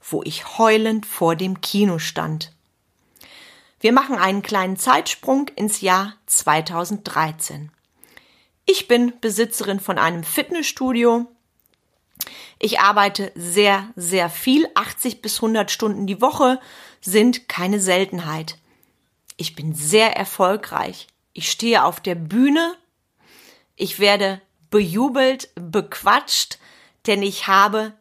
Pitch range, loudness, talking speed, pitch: 185-235 Hz, -19 LUFS, 110 wpm, 205 Hz